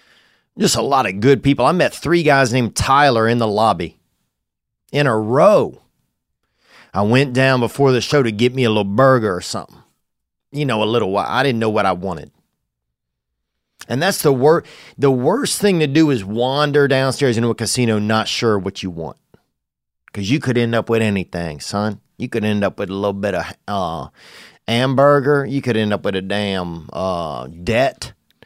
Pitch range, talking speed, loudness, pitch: 100-135 Hz, 190 wpm, -17 LUFS, 115 Hz